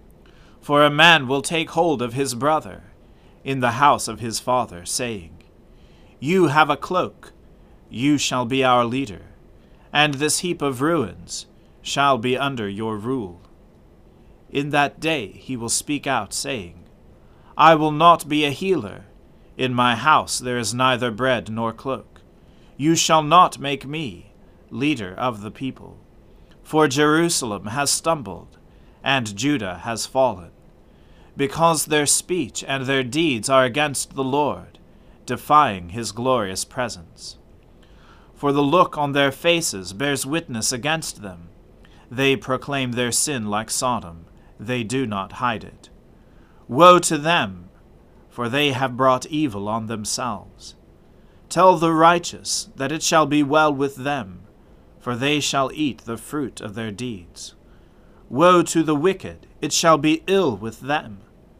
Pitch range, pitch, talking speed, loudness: 110-150 Hz, 130 Hz, 145 wpm, -20 LUFS